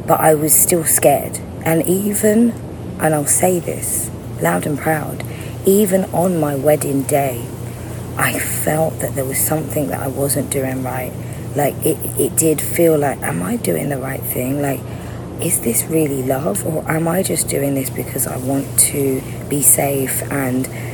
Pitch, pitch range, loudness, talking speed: 135 Hz, 125-155 Hz, -17 LUFS, 170 wpm